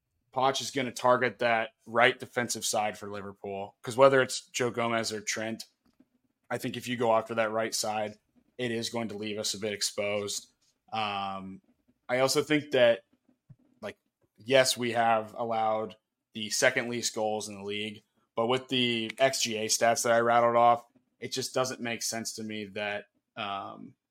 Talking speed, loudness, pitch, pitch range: 175 wpm, -29 LUFS, 115 Hz, 110-125 Hz